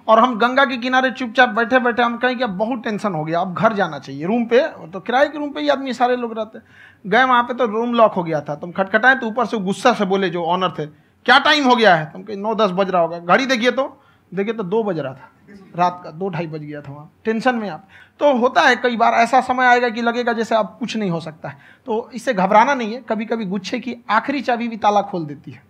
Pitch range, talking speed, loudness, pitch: 190-250 Hz, 270 wpm, -18 LUFS, 225 Hz